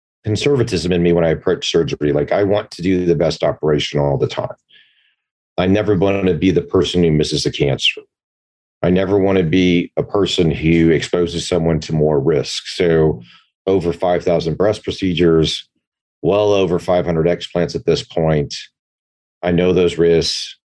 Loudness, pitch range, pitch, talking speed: -16 LUFS, 80-95 Hz, 85 Hz, 175 wpm